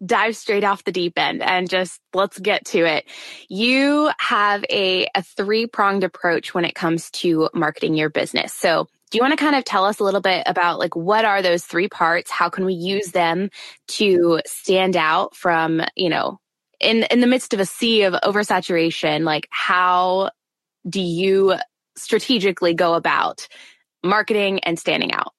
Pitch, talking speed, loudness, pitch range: 190 Hz, 180 wpm, -19 LUFS, 175-210 Hz